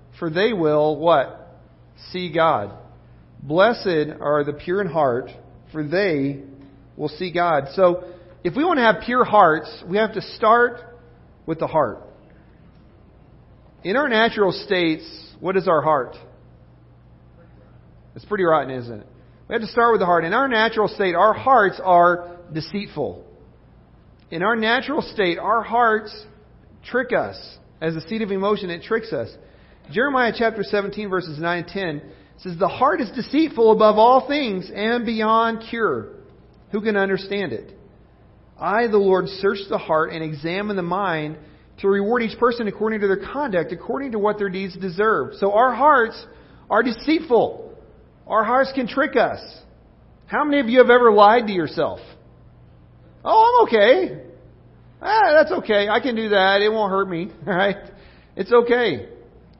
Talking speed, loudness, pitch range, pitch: 160 wpm, -19 LUFS, 165-225 Hz, 200 Hz